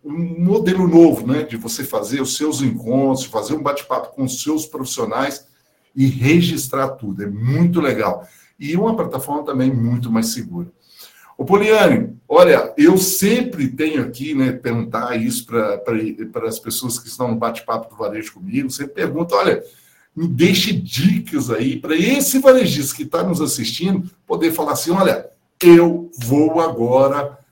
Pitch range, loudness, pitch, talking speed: 130-175 Hz, -17 LUFS, 150 Hz, 155 wpm